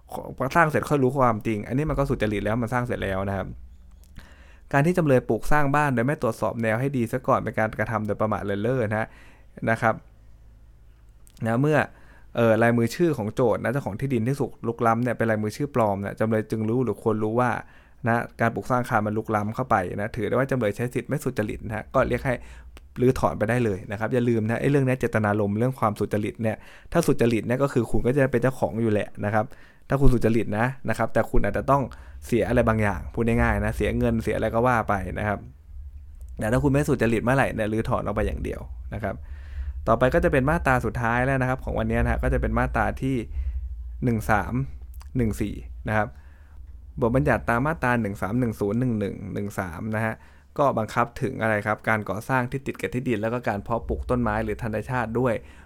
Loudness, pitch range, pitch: -25 LUFS, 105-125 Hz, 110 Hz